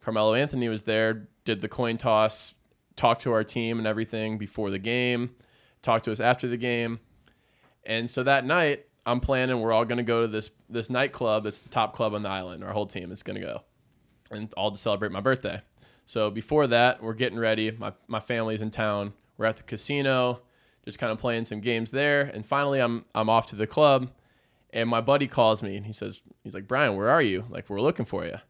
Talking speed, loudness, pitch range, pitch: 225 wpm, -26 LUFS, 110-125 Hz, 115 Hz